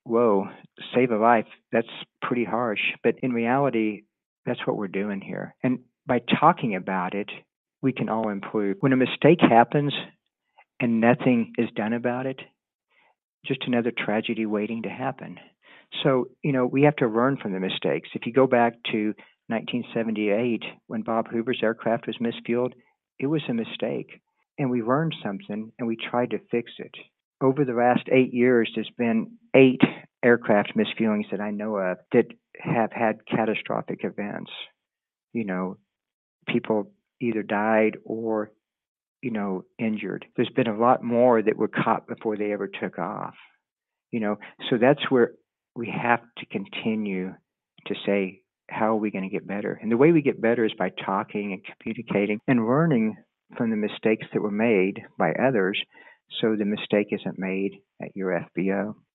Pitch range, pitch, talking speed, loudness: 105-125 Hz, 115 Hz, 165 wpm, -25 LUFS